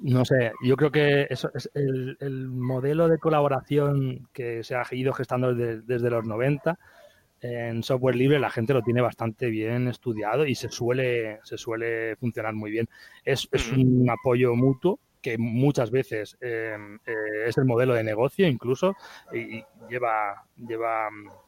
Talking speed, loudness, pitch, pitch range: 160 wpm, -26 LUFS, 125 Hz, 115-135 Hz